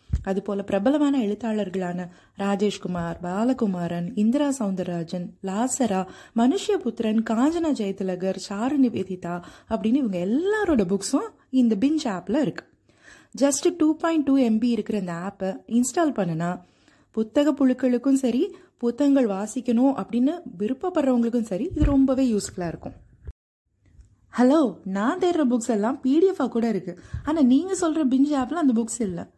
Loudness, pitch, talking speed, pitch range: -24 LUFS, 235 Hz, 120 wpm, 195-275 Hz